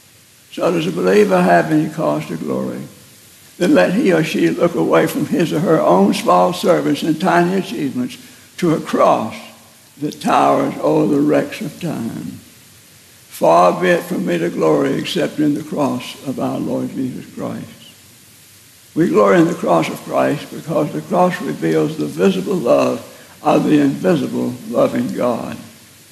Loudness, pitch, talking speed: -16 LUFS, 150 Hz, 165 wpm